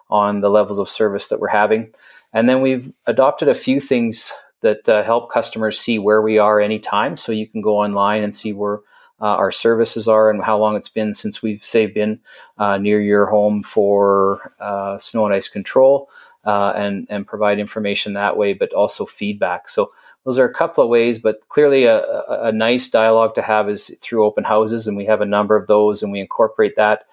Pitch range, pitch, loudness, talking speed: 105-115 Hz, 105 Hz, -17 LUFS, 210 wpm